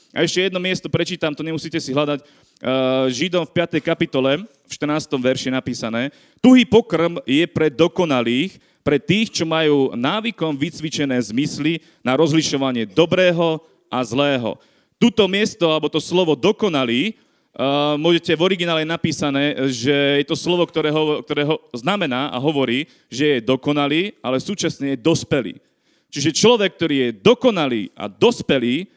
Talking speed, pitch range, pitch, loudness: 140 wpm, 140-170 Hz, 155 Hz, -19 LUFS